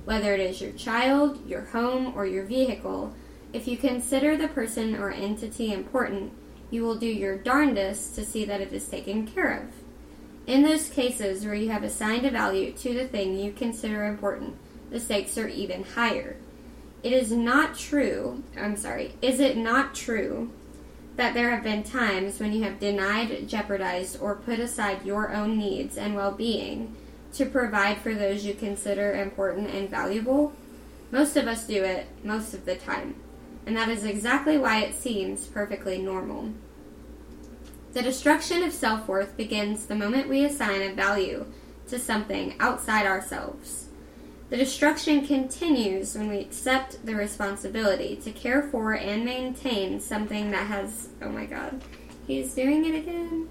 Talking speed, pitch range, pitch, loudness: 165 wpm, 200-255 Hz, 220 Hz, -27 LUFS